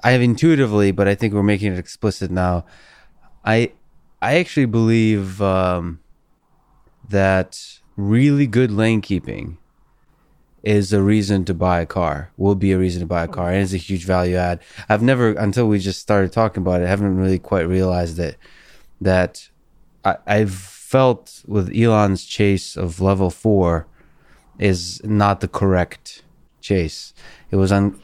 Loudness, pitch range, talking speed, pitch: -19 LUFS, 90-105 Hz, 160 wpm, 100 Hz